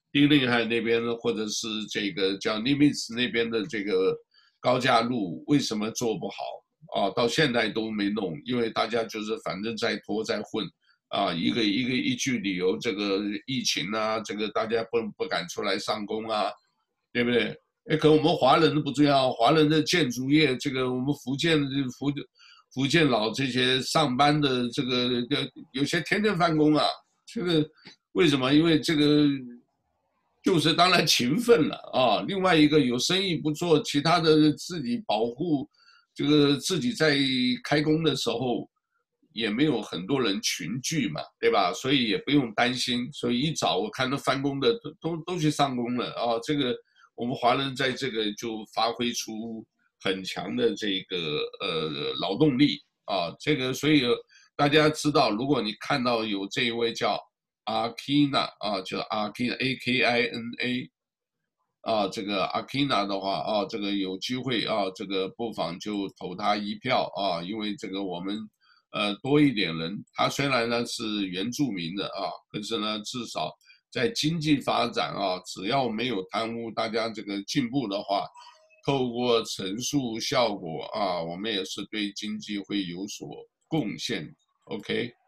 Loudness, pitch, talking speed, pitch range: -26 LUFS, 125 Hz, 240 characters per minute, 115-155 Hz